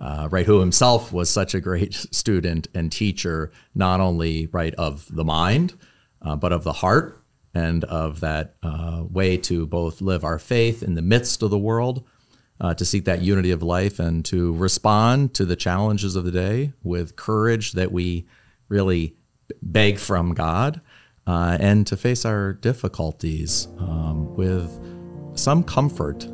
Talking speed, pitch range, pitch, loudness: 165 wpm, 85-105 Hz, 90 Hz, -22 LUFS